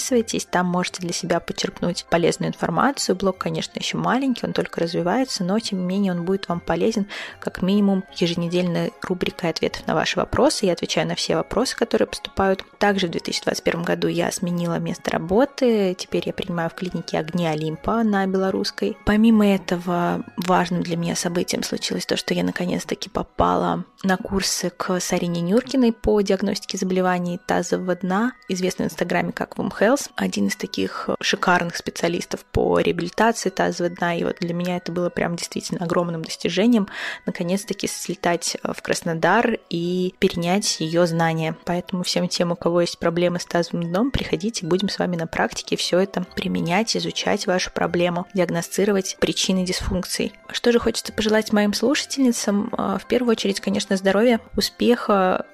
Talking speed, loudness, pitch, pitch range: 160 wpm, -22 LUFS, 185 Hz, 175-210 Hz